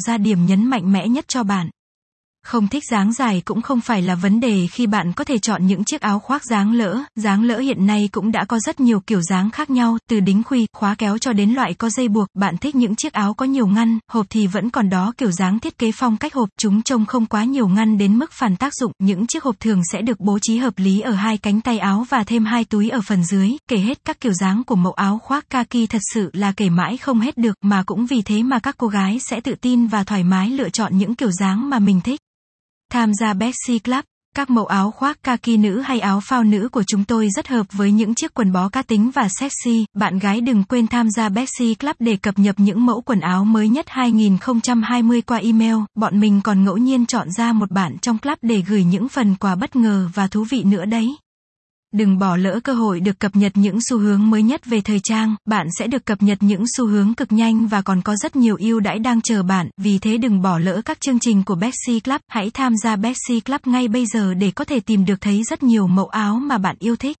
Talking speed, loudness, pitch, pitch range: 255 wpm, -18 LUFS, 220 Hz, 205-245 Hz